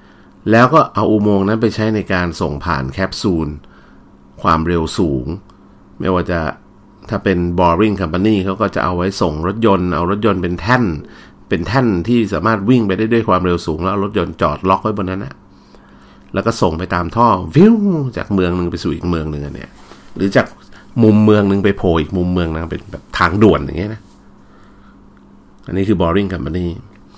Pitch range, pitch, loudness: 85-105 Hz, 95 Hz, -15 LUFS